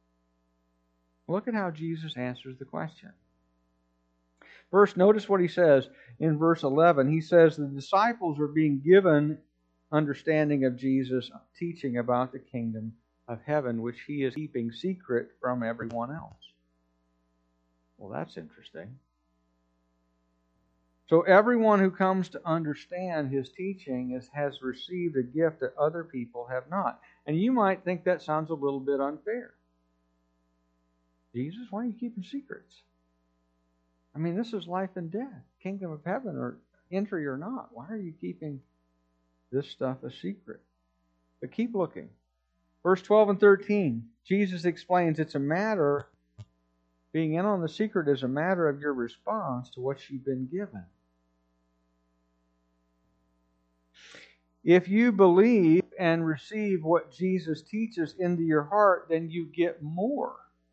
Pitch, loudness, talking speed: 140 Hz, -27 LUFS, 140 wpm